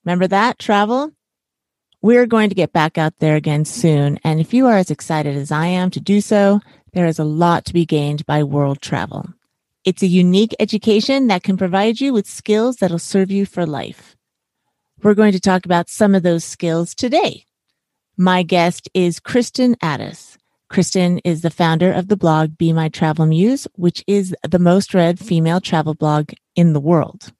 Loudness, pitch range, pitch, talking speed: -16 LUFS, 160-200 Hz, 180 Hz, 190 wpm